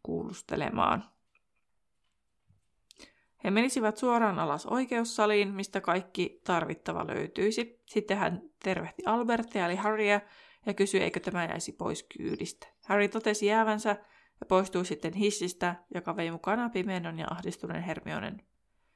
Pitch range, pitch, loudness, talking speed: 175-215 Hz, 200 Hz, -31 LUFS, 115 wpm